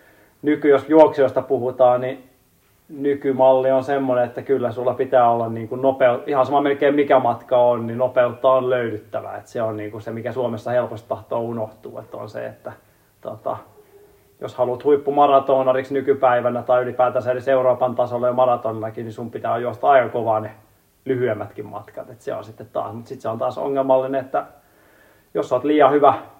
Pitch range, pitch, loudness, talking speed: 115-135 Hz, 125 Hz, -19 LUFS, 165 wpm